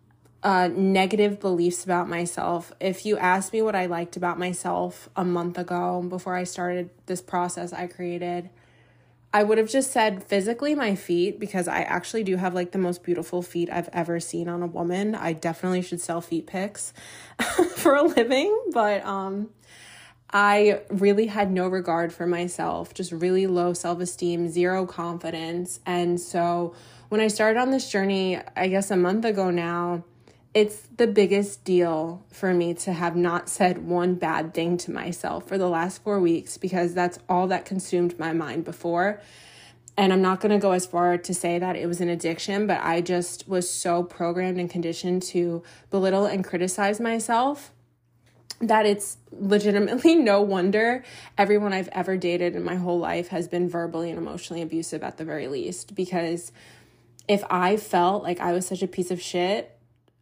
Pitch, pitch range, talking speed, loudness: 180 Hz, 170-195 Hz, 175 wpm, -25 LUFS